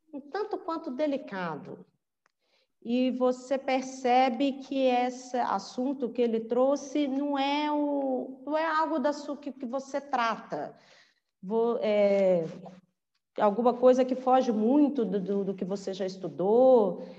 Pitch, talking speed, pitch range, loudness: 255 Hz, 135 wpm, 210-280 Hz, -28 LUFS